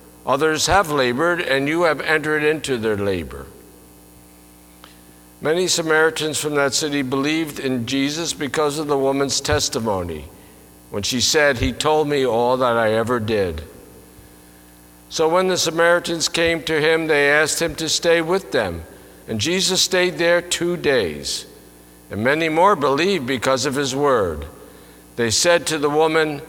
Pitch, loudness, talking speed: 145 Hz, -19 LUFS, 150 wpm